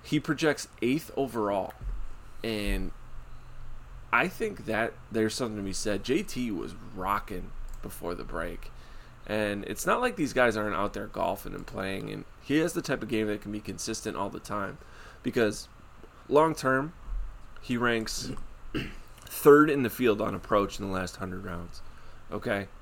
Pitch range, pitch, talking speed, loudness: 100-130 Hz, 110 Hz, 165 wpm, -29 LUFS